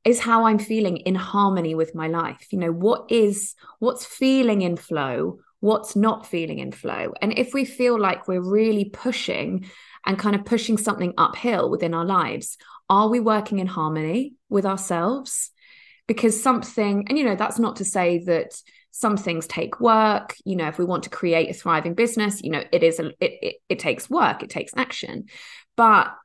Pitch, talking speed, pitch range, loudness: 215 Hz, 190 wpm, 185-245 Hz, -22 LUFS